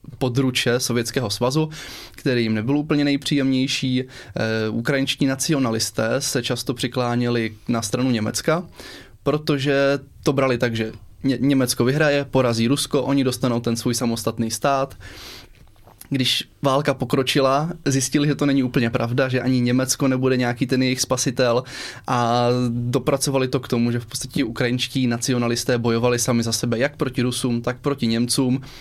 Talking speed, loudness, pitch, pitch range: 140 wpm, -21 LUFS, 130 Hz, 120-140 Hz